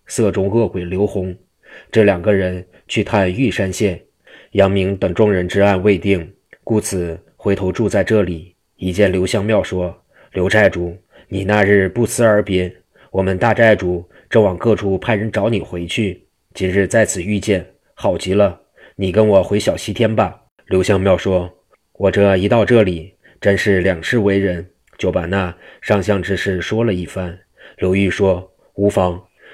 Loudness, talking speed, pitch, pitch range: -17 LUFS, 225 characters per minute, 95 Hz, 90-105 Hz